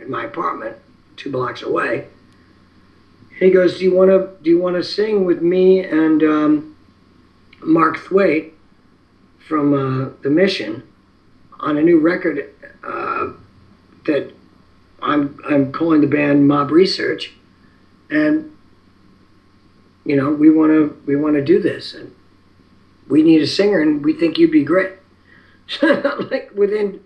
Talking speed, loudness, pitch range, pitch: 145 wpm, -16 LUFS, 130-200 Hz, 155 Hz